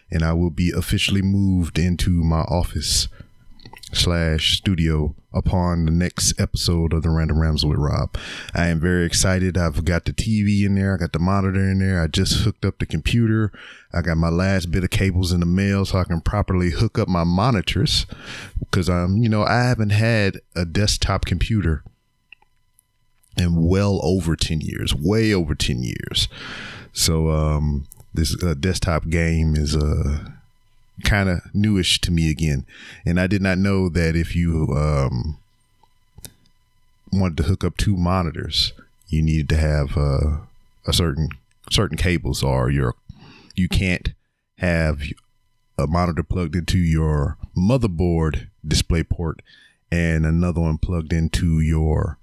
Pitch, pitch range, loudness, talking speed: 90 Hz, 80-100 Hz, -21 LUFS, 155 wpm